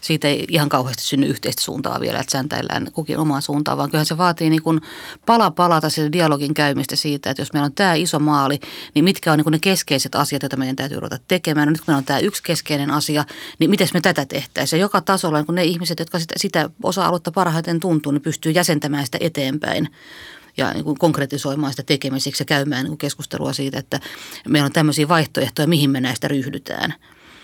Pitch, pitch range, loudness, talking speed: 150 Hz, 140-170 Hz, -19 LUFS, 205 wpm